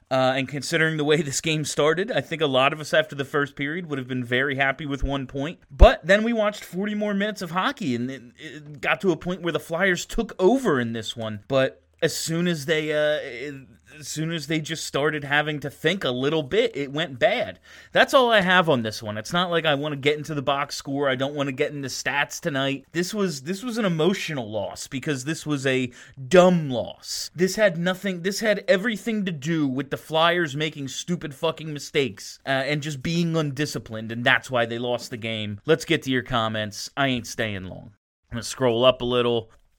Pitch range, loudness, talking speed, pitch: 130-170 Hz, -24 LUFS, 230 wpm, 150 Hz